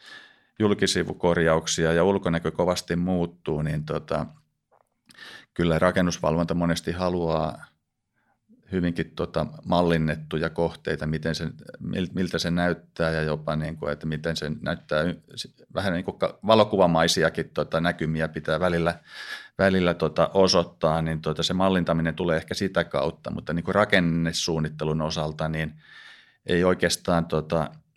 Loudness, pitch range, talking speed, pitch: -25 LUFS, 80-90 Hz, 120 wpm, 85 Hz